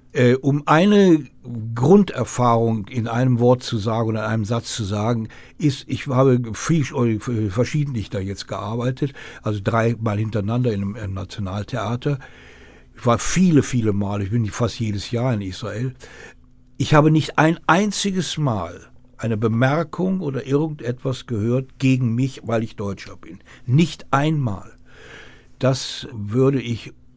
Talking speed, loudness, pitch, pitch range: 135 wpm, -21 LUFS, 120 Hz, 110-135 Hz